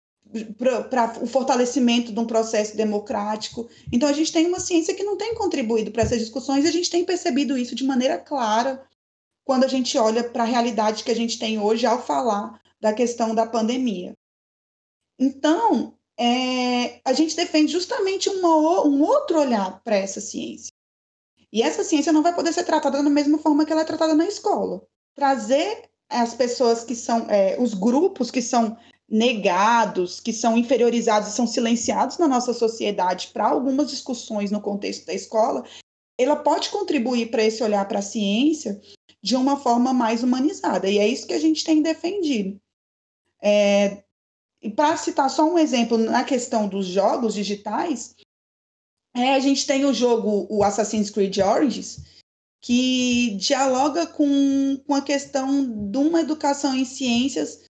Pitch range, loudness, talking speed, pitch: 225-295 Hz, -22 LUFS, 165 wpm, 250 Hz